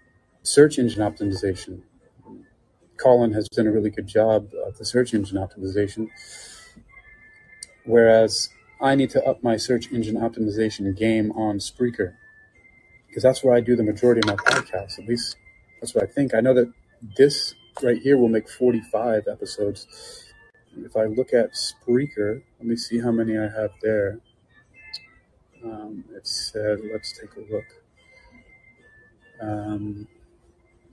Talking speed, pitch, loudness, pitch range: 145 wpm, 110 Hz, -22 LUFS, 105-120 Hz